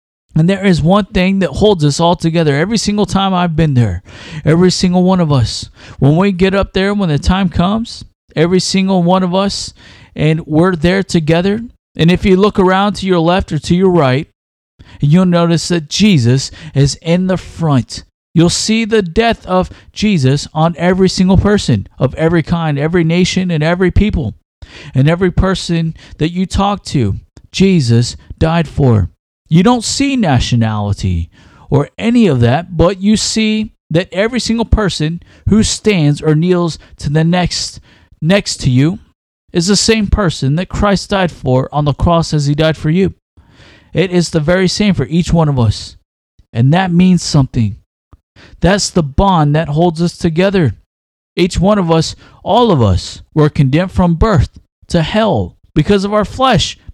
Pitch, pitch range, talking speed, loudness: 170 Hz, 140-190 Hz, 175 wpm, -13 LUFS